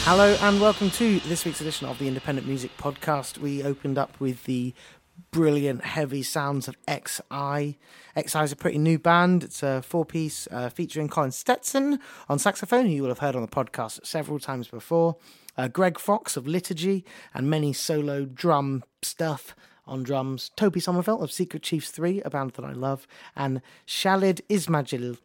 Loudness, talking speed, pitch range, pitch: -26 LUFS, 175 wpm, 135-175 Hz, 150 Hz